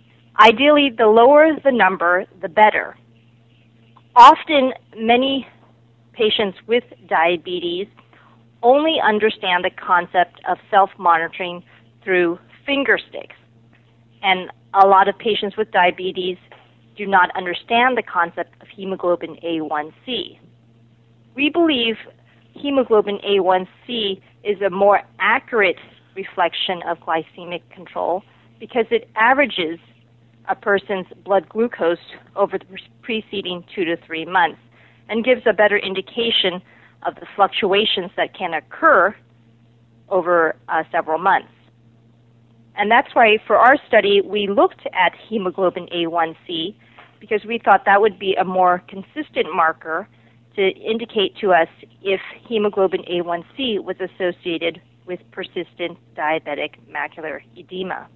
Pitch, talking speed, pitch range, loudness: 185 Hz, 115 wpm, 155-210 Hz, -18 LUFS